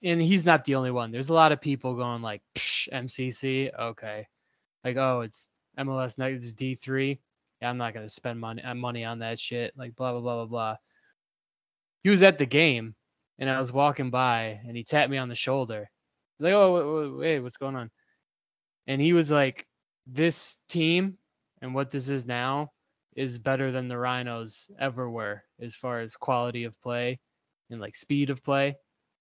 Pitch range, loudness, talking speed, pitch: 120-140 Hz, -27 LUFS, 195 wpm, 130 Hz